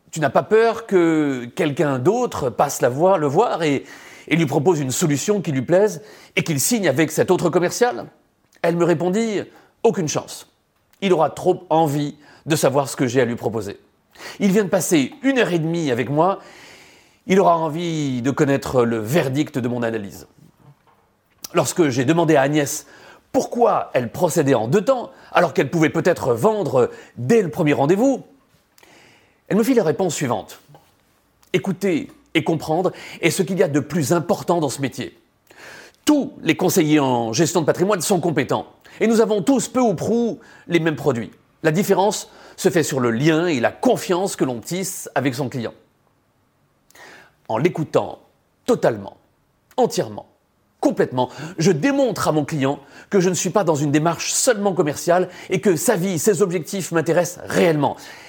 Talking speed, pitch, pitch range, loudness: 175 wpm, 175 Hz, 150-200 Hz, -19 LUFS